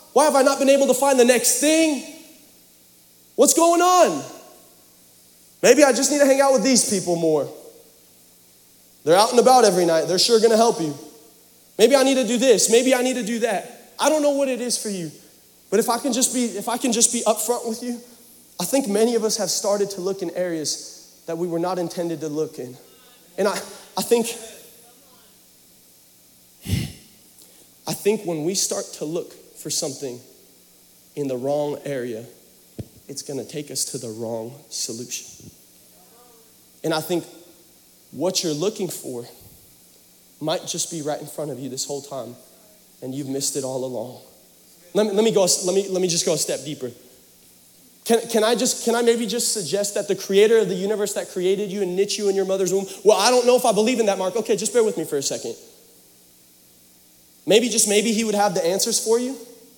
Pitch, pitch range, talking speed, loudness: 195 Hz, 145-235 Hz, 205 wpm, -20 LUFS